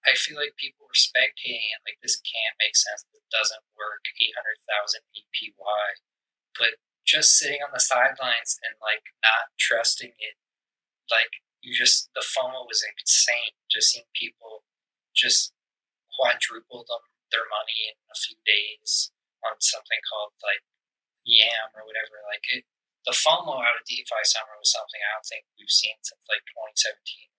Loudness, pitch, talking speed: -22 LUFS, 290 Hz, 165 wpm